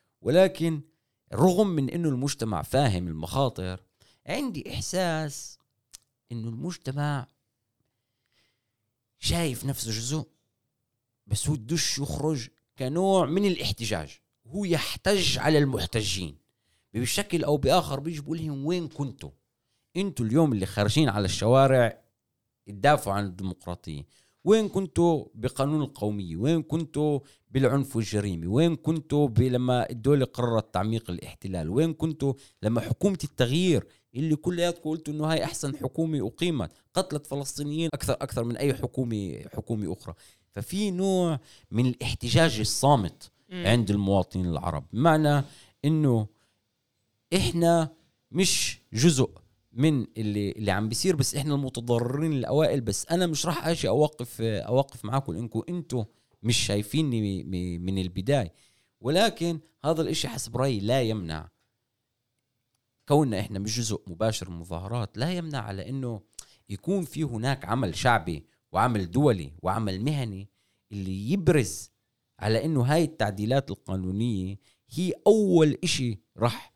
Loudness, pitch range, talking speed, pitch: -27 LUFS, 110-155 Hz, 120 wpm, 125 Hz